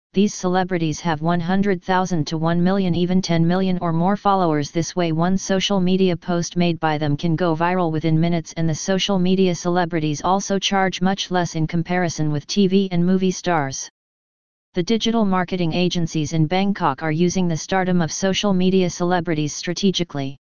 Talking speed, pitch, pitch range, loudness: 170 wpm, 175 Hz, 165-190 Hz, -20 LUFS